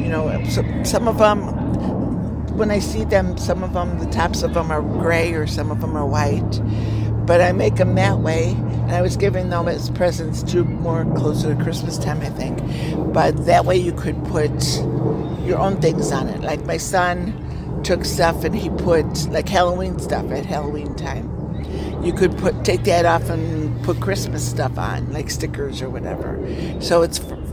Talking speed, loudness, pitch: 190 wpm, -20 LUFS, 105 Hz